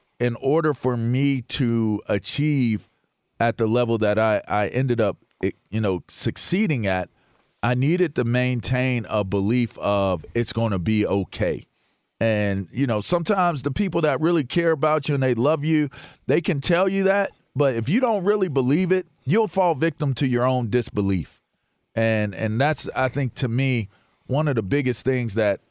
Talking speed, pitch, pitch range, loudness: 180 wpm, 125 Hz, 110-155 Hz, -22 LUFS